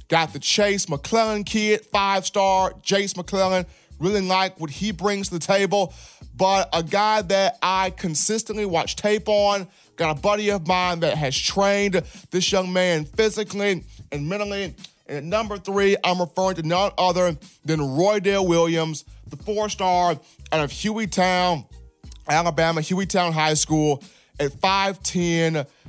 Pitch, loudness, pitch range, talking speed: 185 Hz, -22 LUFS, 165-200 Hz, 160 wpm